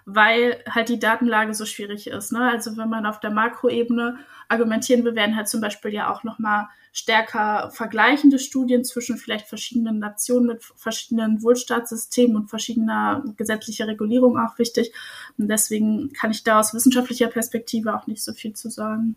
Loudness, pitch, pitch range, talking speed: -21 LUFS, 225 Hz, 215-240 Hz, 165 wpm